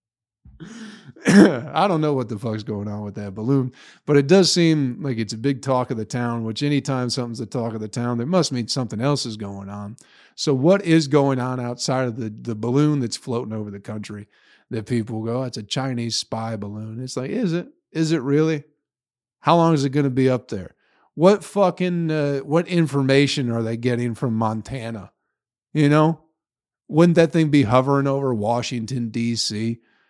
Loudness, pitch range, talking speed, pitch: -21 LUFS, 115-150 Hz, 195 wpm, 130 Hz